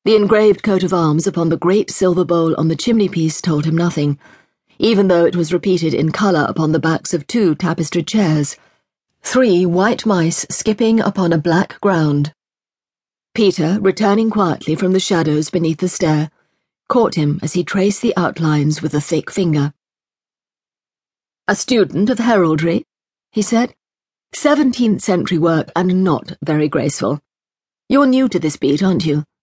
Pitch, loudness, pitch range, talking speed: 175 Hz, -16 LUFS, 160-200 Hz, 155 wpm